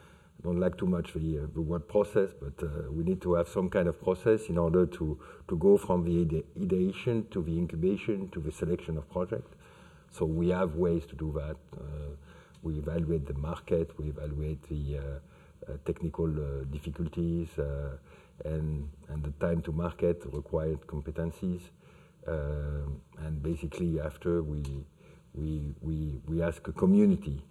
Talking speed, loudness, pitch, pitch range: 165 wpm, -32 LUFS, 80 Hz, 75-85 Hz